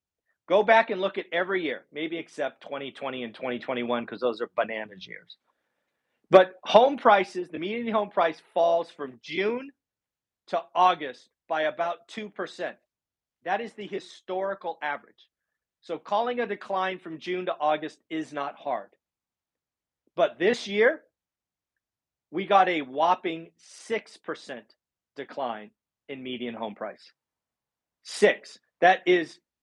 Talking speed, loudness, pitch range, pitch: 130 wpm, -26 LUFS, 145-200 Hz, 170 Hz